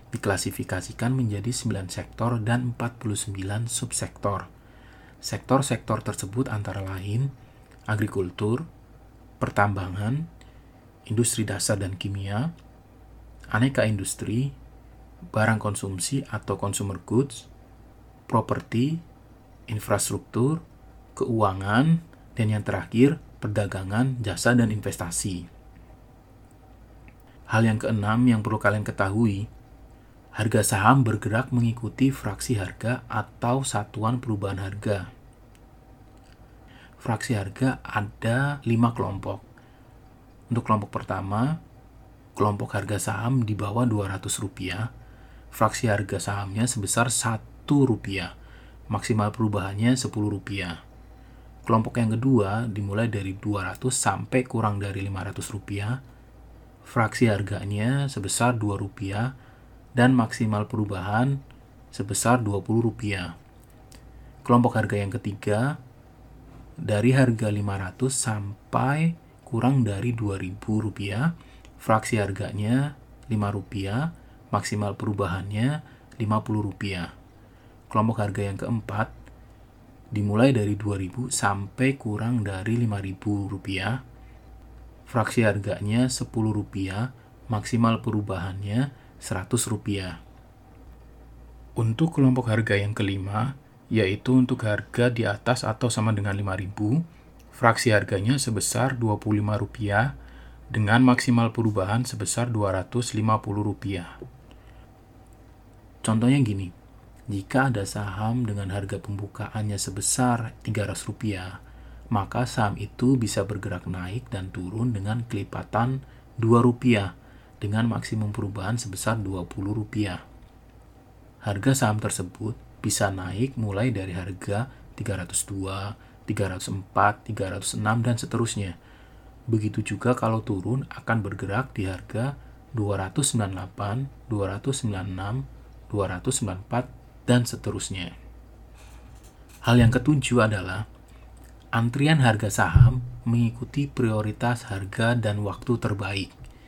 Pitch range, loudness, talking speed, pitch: 100-125 Hz, -26 LUFS, 90 wpm, 110 Hz